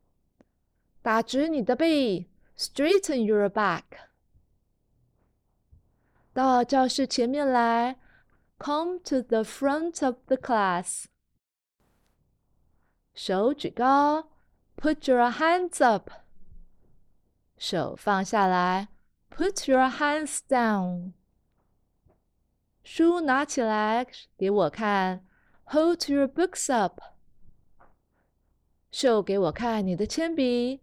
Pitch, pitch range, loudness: 255 Hz, 215-295 Hz, -26 LUFS